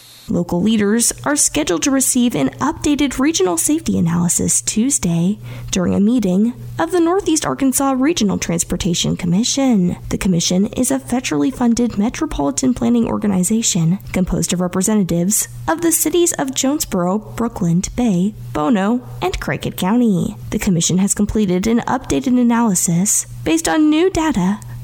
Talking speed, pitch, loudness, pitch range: 135 wpm, 210 Hz, -16 LUFS, 175-260 Hz